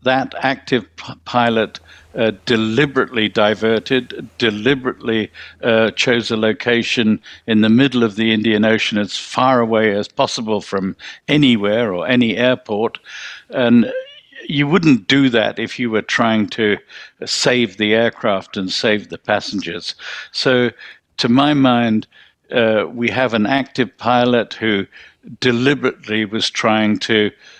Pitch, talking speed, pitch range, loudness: 115 Hz, 135 wpm, 110-125 Hz, -16 LUFS